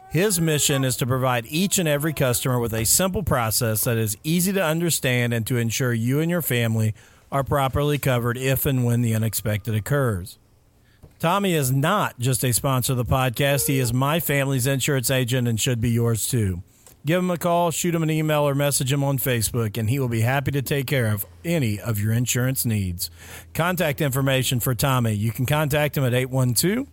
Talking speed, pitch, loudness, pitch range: 205 wpm, 130 Hz, -22 LUFS, 115-145 Hz